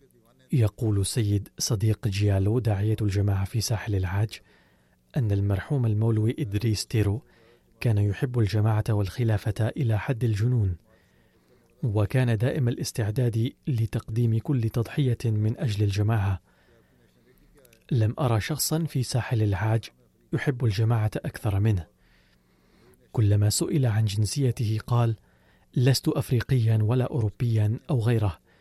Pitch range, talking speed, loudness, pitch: 105-120 Hz, 105 wpm, -26 LUFS, 110 Hz